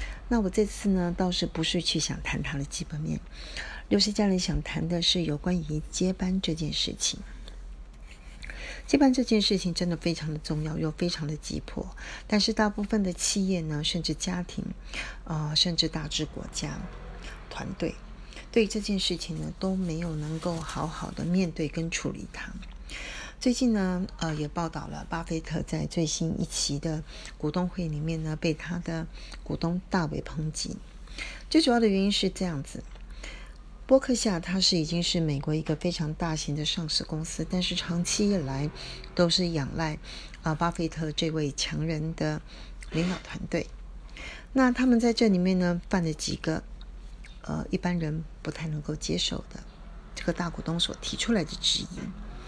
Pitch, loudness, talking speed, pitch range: 170 Hz, -29 LUFS, 250 characters per minute, 155-190 Hz